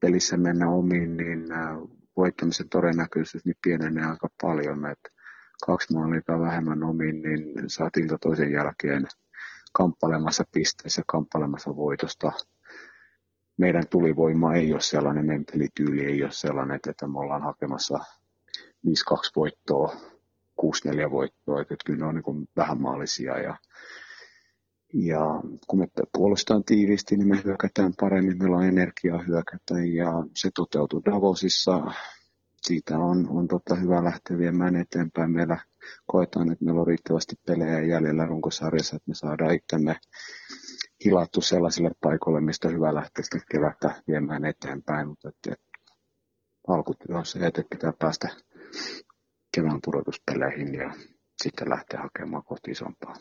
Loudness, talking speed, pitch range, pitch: -26 LUFS, 125 wpm, 75-85 Hz, 80 Hz